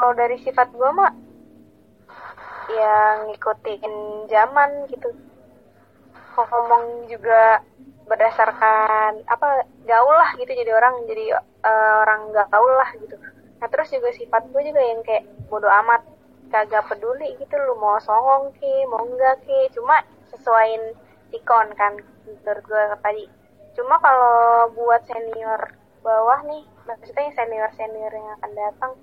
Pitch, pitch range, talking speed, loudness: 235 Hz, 215-270 Hz, 130 wpm, -19 LUFS